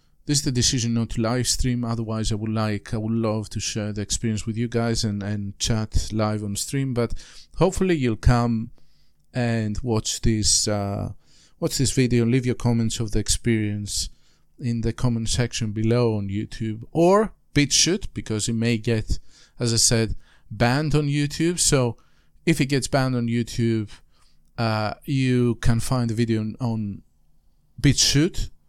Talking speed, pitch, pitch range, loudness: 170 wpm, 115 Hz, 105-125 Hz, -23 LUFS